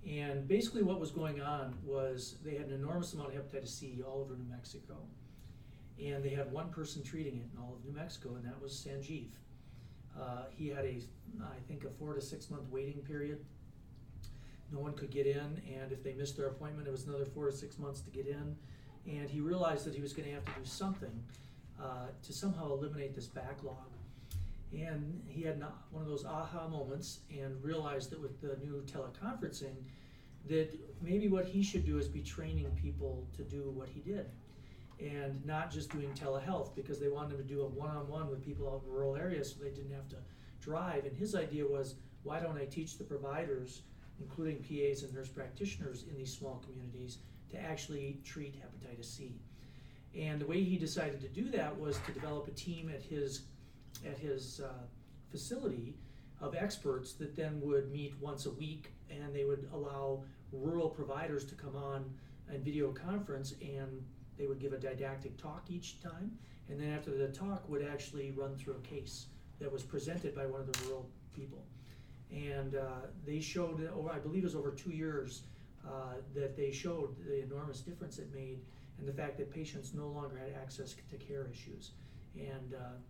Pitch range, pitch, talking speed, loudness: 130-150 Hz, 140 Hz, 195 wpm, -42 LUFS